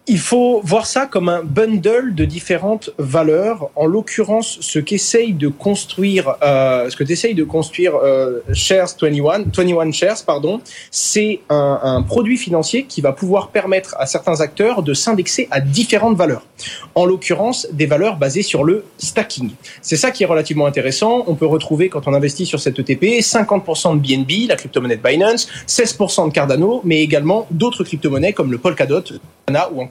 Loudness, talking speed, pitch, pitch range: -16 LUFS, 175 wpm, 175 Hz, 150-215 Hz